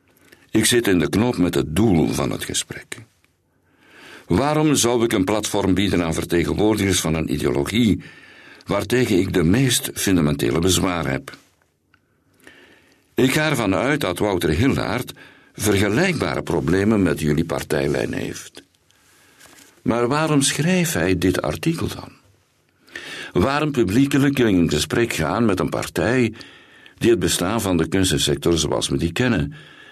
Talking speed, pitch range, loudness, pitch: 135 wpm, 85-120 Hz, -20 LUFS, 95 Hz